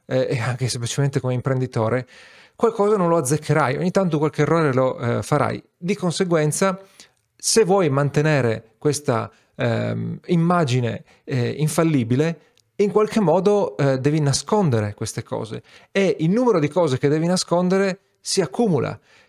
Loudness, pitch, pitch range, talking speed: -21 LUFS, 155 Hz, 130-185 Hz, 135 wpm